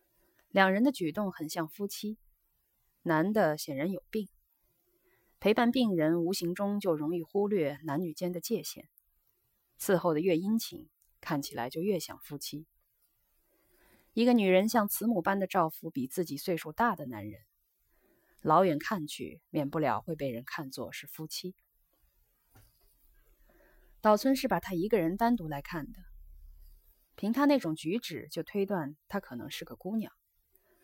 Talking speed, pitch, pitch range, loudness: 215 characters per minute, 170 Hz, 150-205 Hz, -31 LUFS